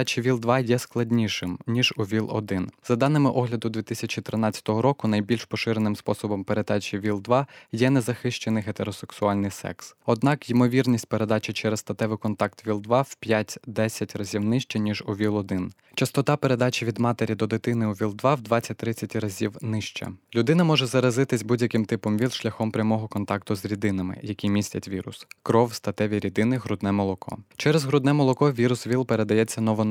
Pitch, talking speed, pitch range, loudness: 110 Hz, 145 wpm, 105-125 Hz, -25 LUFS